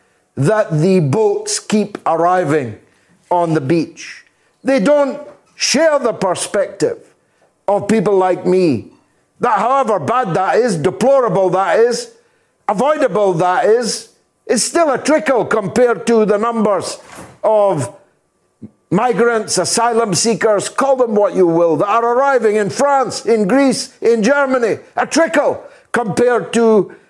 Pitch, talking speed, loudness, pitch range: 230 Hz, 130 wpm, -14 LUFS, 190-270 Hz